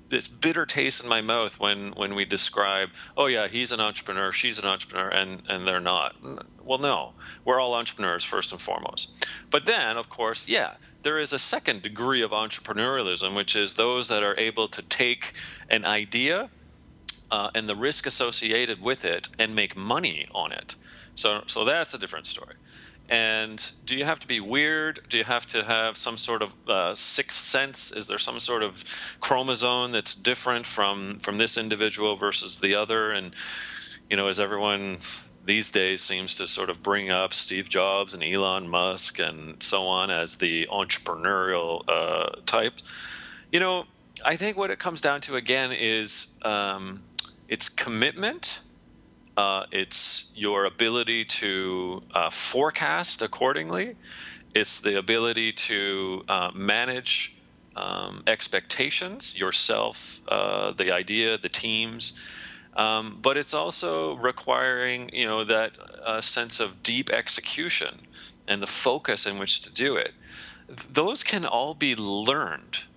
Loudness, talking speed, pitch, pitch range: -25 LUFS, 160 wpm, 105 Hz, 95-120 Hz